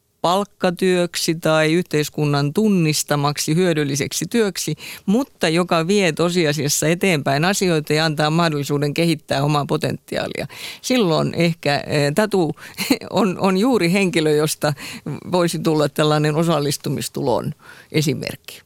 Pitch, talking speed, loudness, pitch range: 165 Hz, 100 wpm, -19 LUFS, 150-185 Hz